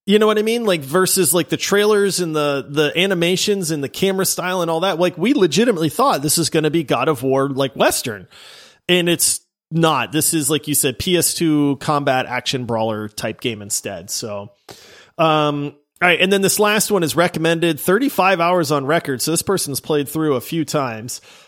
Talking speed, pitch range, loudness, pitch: 205 wpm, 145-185 Hz, -17 LUFS, 160 Hz